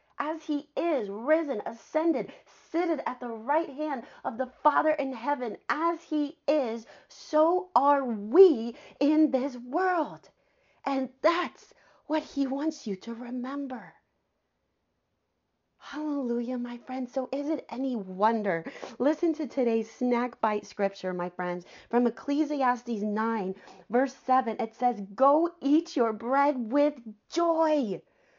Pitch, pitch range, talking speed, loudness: 270 Hz, 235-305 Hz, 130 wpm, -28 LUFS